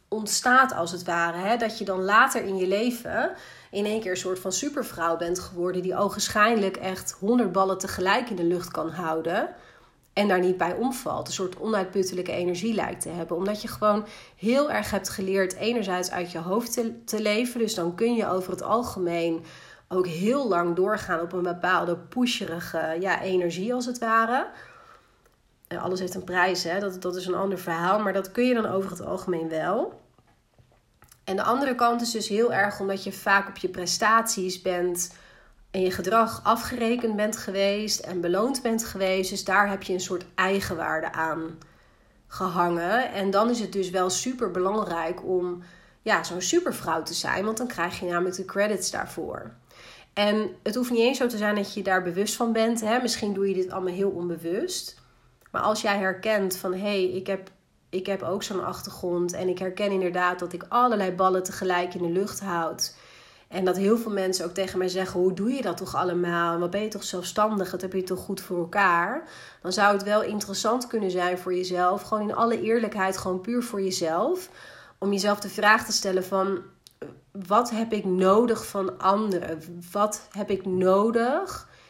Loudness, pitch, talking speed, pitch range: -26 LUFS, 190 Hz, 195 wpm, 180-215 Hz